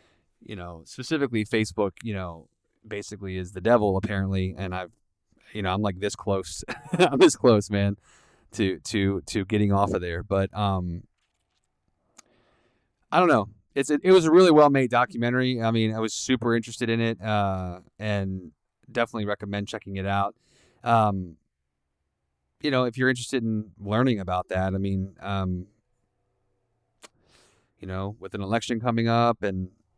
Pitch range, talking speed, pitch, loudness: 95-115 Hz, 160 wpm, 105 Hz, -25 LUFS